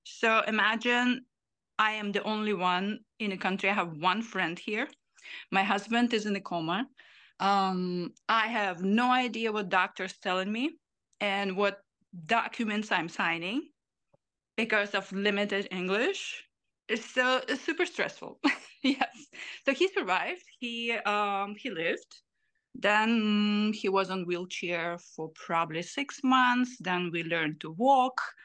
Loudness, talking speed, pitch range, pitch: -29 LUFS, 140 wpm, 190-245 Hz, 210 Hz